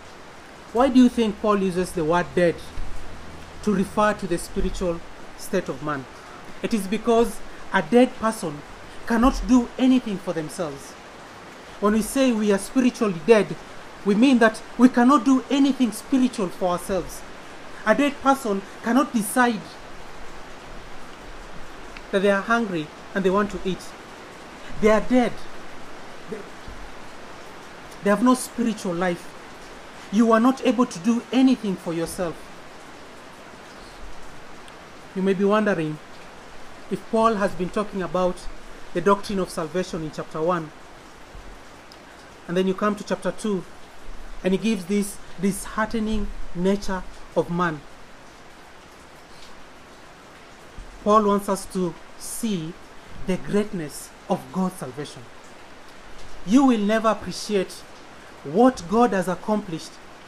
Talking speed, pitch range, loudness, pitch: 125 wpm, 180-225 Hz, -23 LUFS, 200 Hz